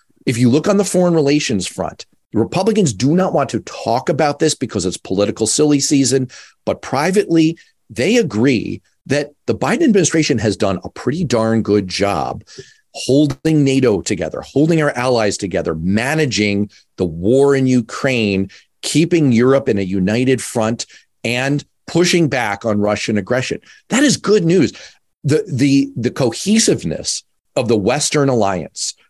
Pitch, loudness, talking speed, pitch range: 135 Hz, -16 LUFS, 150 wpm, 110-155 Hz